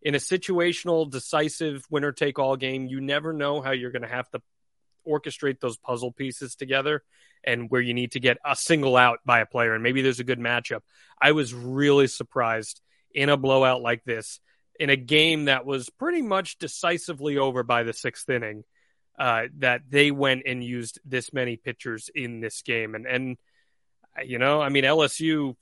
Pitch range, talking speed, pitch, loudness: 125-145 Hz, 190 wpm, 135 Hz, -24 LUFS